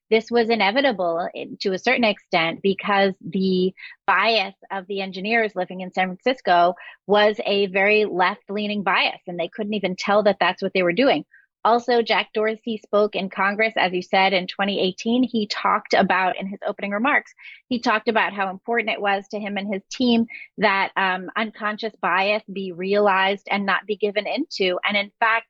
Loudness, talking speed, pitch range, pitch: -21 LUFS, 180 wpm, 190-225 Hz, 205 Hz